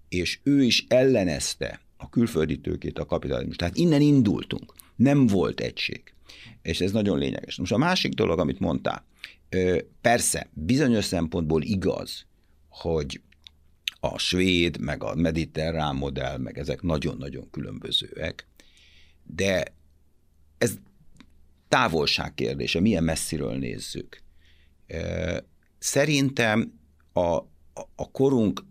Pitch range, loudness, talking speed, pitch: 75-95 Hz, -25 LUFS, 105 wpm, 80 Hz